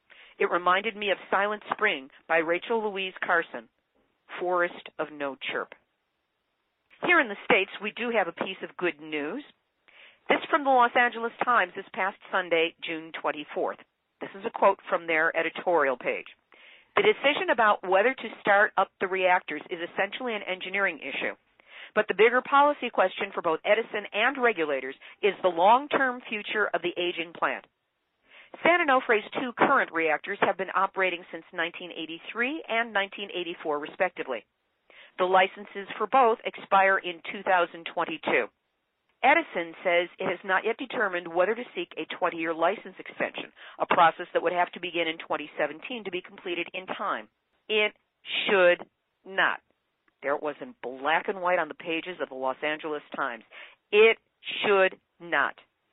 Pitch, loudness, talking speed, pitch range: 190 Hz, -26 LUFS, 155 wpm, 170-220 Hz